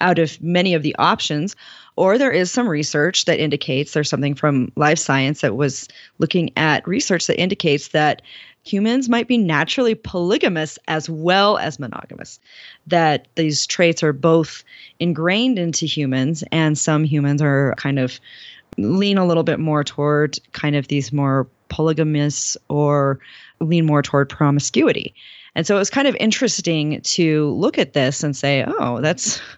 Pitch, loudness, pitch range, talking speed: 155 Hz, -18 LUFS, 145-175 Hz, 160 wpm